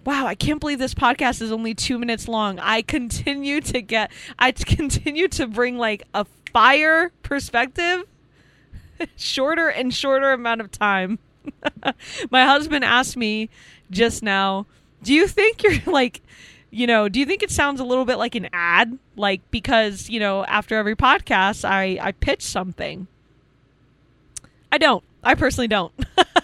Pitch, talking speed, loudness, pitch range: 235 Hz, 155 wpm, -20 LUFS, 200-275 Hz